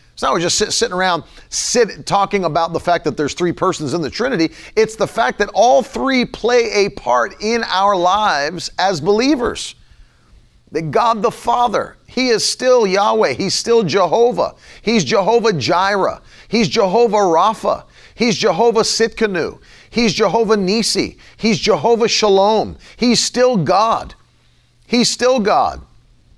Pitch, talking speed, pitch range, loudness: 220 Hz, 145 wpm, 190-235 Hz, -15 LUFS